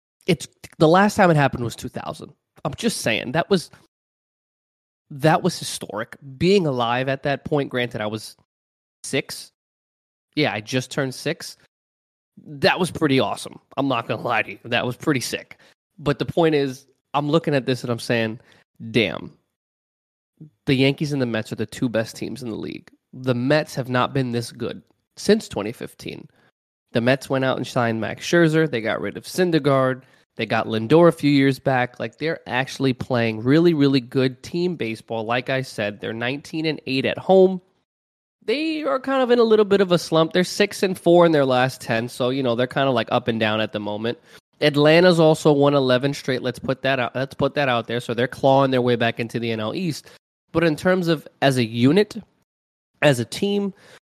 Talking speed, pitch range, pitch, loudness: 200 wpm, 120-160 Hz, 135 Hz, -21 LUFS